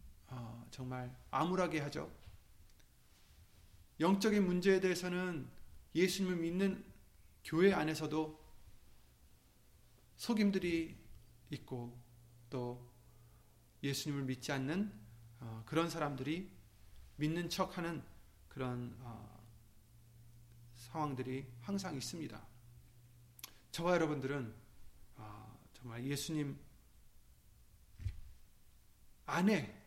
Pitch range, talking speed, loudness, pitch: 105-155 Hz, 175 characters per minute, -39 LUFS, 120 Hz